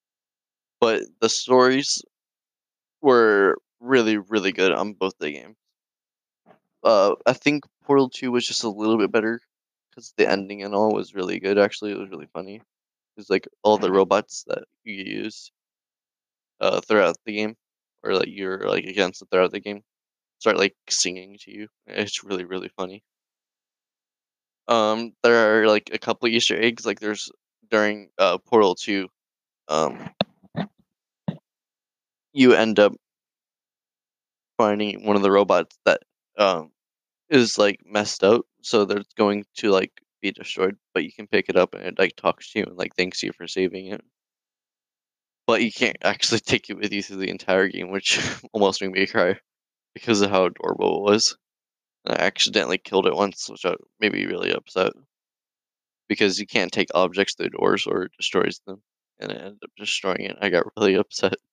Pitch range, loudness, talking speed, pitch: 95-110 Hz, -22 LUFS, 170 wpm, 105 Hz